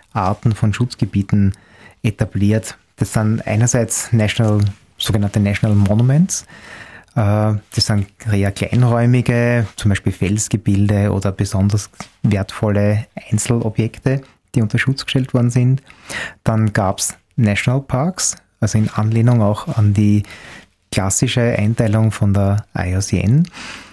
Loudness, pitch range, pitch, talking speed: -17 LUFS, 100-120 Hz, 110 Hz, 110 wpm